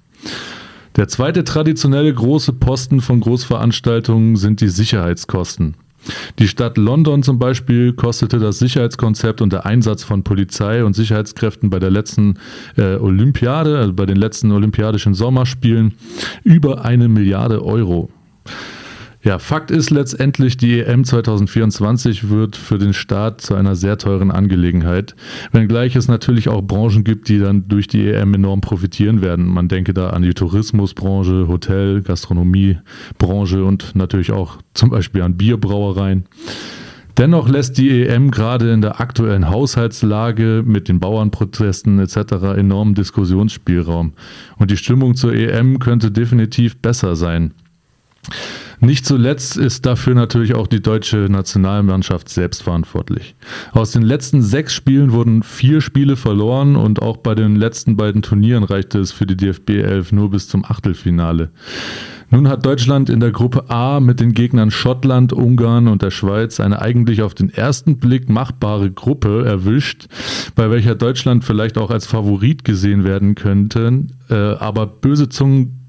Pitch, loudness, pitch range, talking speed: 110 Hz, -15 LUFS, 100-125 Hz, 145 wpm